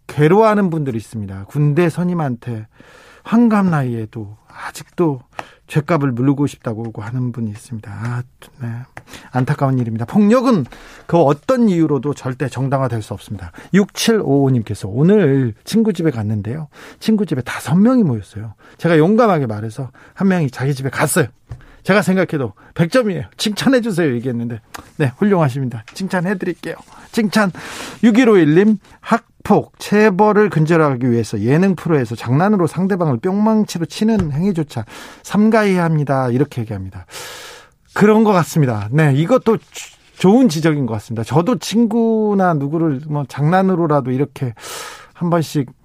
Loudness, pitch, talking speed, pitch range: -16 LUFS, 150 Hz, 325 characters per minute, 125-195 Hz